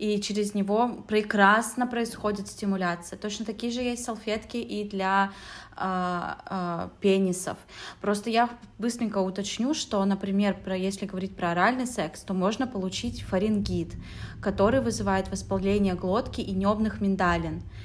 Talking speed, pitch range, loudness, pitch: 130 wpm, 190-220 Hz, -27 LUFS, 200 Hz